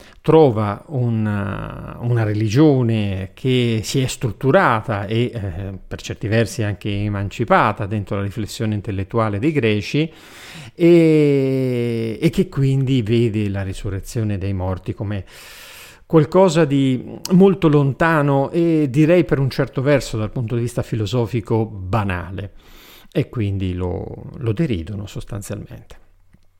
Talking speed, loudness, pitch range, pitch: 120 wpm, -19 LUFS, 105-140 Hz, 115 Hz